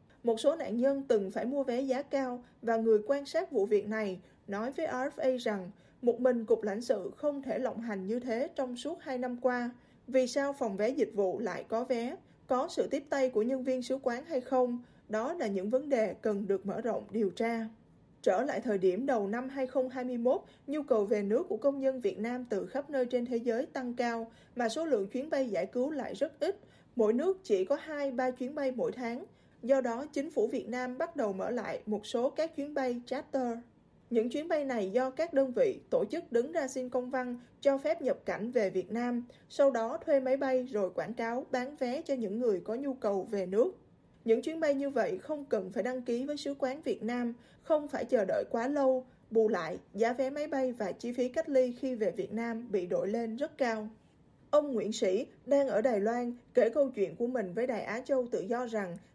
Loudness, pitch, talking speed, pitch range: -33 LUFS, 250 Hz, 230 wpm, 225-275 Hz